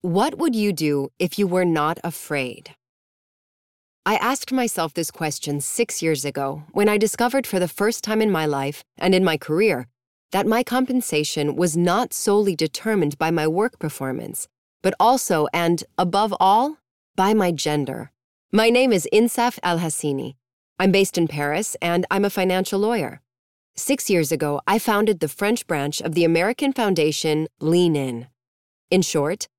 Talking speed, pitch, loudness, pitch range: 160 wpm, 175 Hz, -21 LUFS, 150-210 Hz